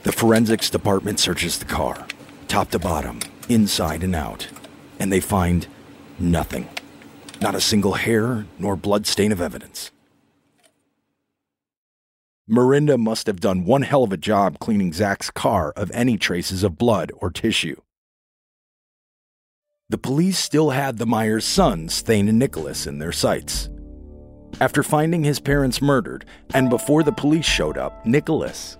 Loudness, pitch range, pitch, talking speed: -20 LUFS, 90-135 Hz, 105 Hz, 145 wpm